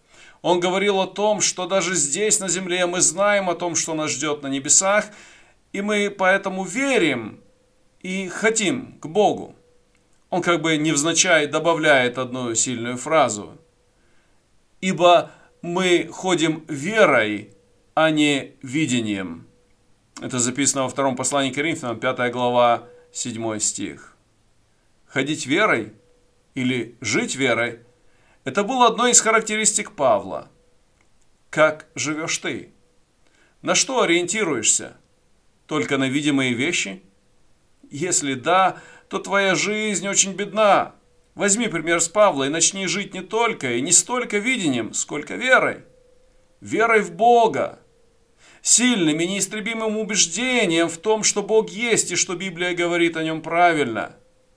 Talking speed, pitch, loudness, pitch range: 125 wpm, 170 Hz, -20 LUFS, 135-200 Hz